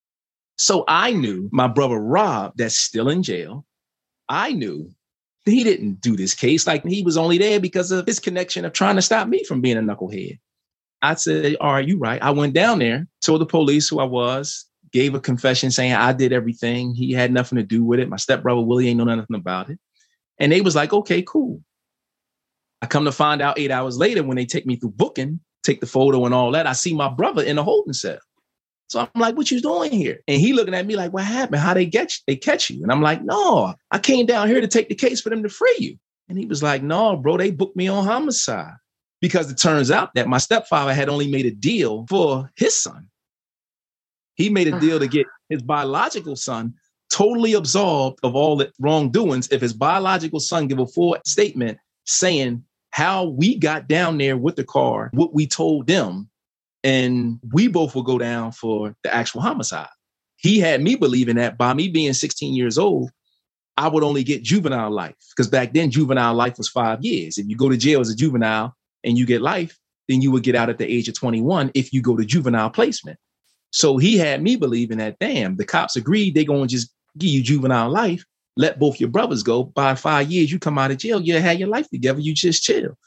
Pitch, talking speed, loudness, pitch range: 145 Hz, 225 wpm, -19 LUFS, 125-180 Hz